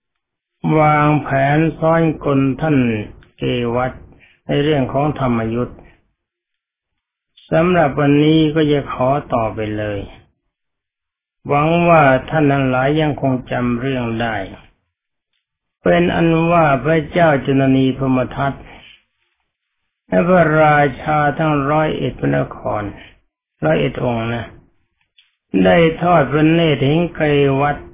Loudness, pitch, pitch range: -16 LUFS, 140 Hz, 125-155 Hz